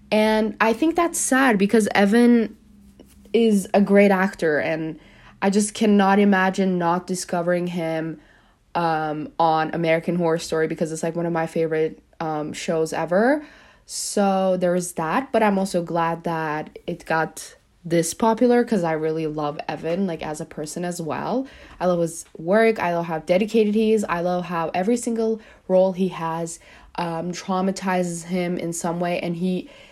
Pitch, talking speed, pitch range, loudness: 180 Hz, 165 wpm, 165-205 Hz, -22 LUFS